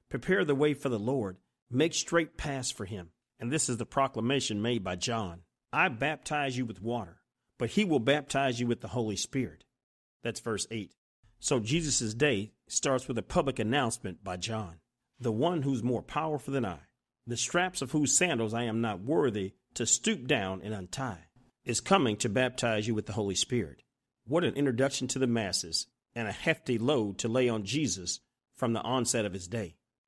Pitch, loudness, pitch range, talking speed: 120 Hz, -31 LUFS, 110-135 Hz, 190 wpm